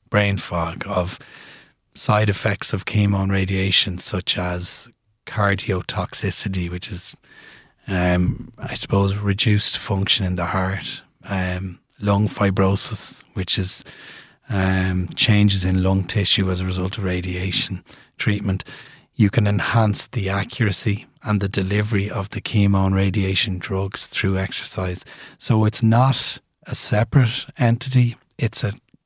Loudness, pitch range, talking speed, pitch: -20 LUFS, 95-110 Hz, 130 wpm, 100 Hz